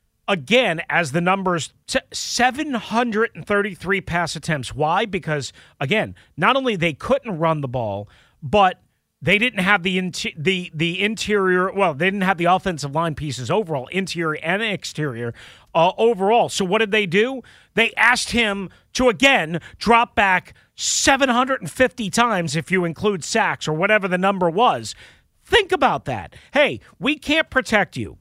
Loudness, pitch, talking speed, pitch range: -20 LUFS, 190 Hz, 150 wpm, 165-225 Hz